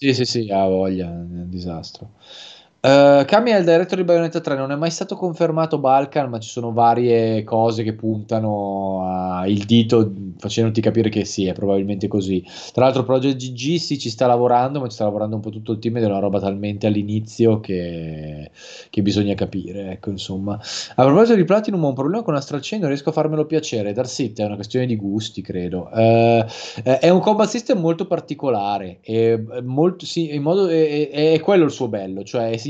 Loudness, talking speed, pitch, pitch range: -19 LUFS, 200 wpm, 115 Hz, 100-145 Hz